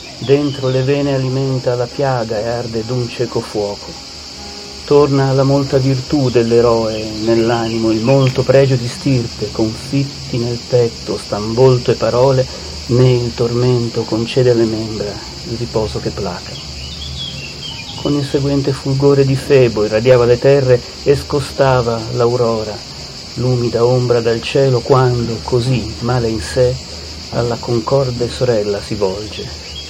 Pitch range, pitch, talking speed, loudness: 110-130 Hz, 120 Hz, 130 wpm, -15 LUFS